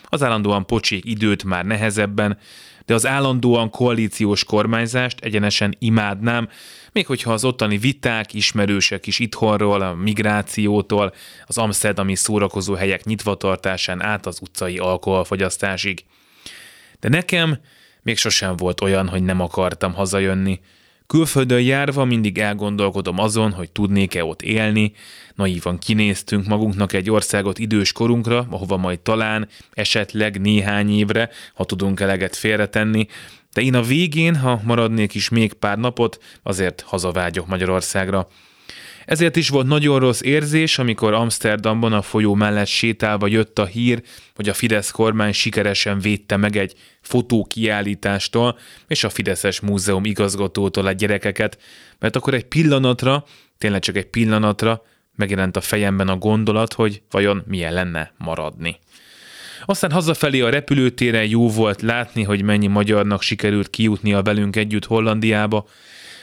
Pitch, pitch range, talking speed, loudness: 105 Hz, 100-115 Hz, 130 wpm, -19 LUFS